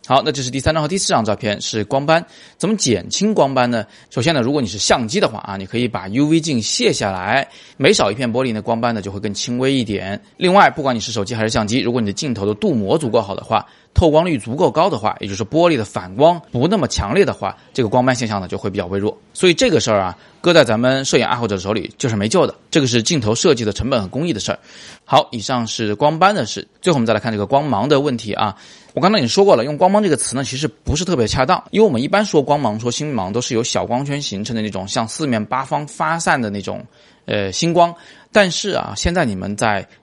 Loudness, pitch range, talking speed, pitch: -17 LUFS, 110-155 Hz, 380 characters per minute, 125 Hz